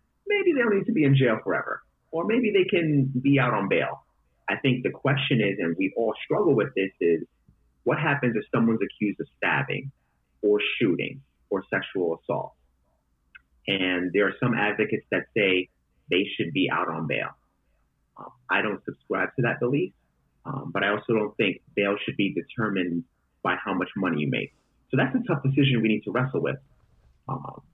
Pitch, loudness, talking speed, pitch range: 110 Hz, -25 LUFS, 190 wpm, 95-140 Hz